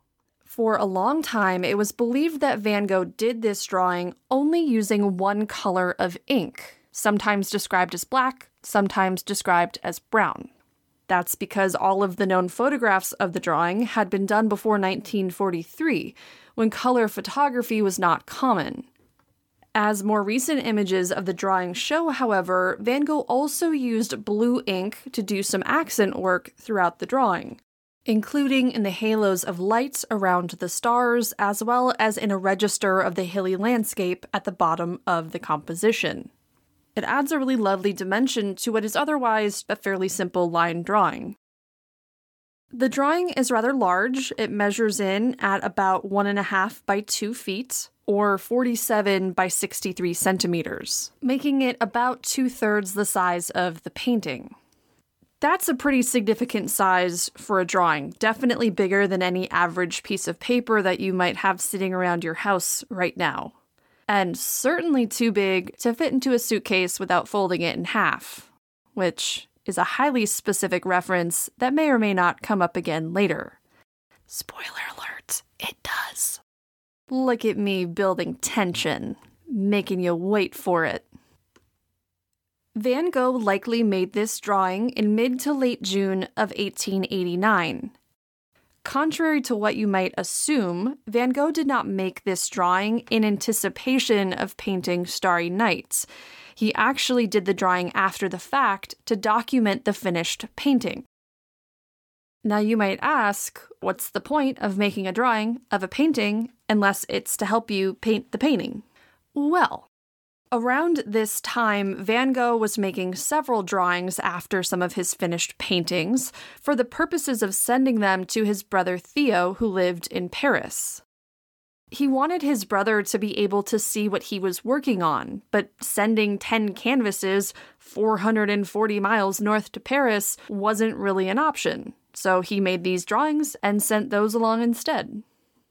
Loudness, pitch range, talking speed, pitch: -23 LUFS, 190-245 Hz, 155 wpm, 210 Hz